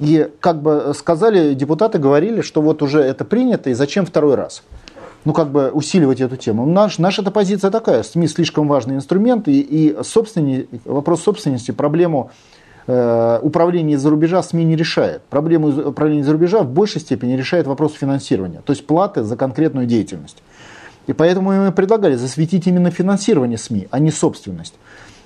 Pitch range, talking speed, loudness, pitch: 140-180 Hz, 165 wpm, -16 LUFS, 155 Hz